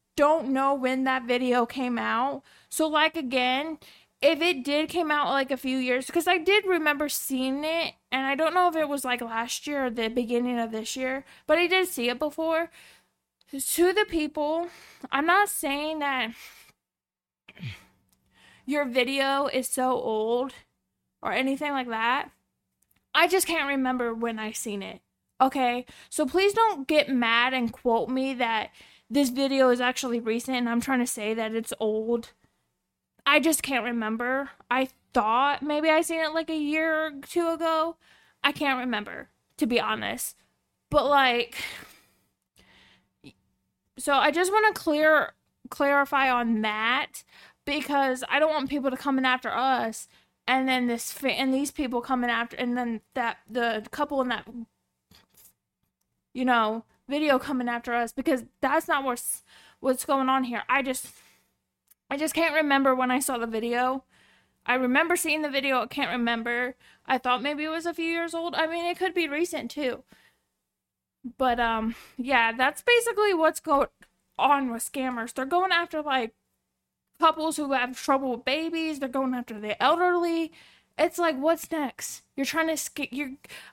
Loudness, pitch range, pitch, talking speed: -26 LUFS, 245-310 Hz, 270 Hz, 170 wpm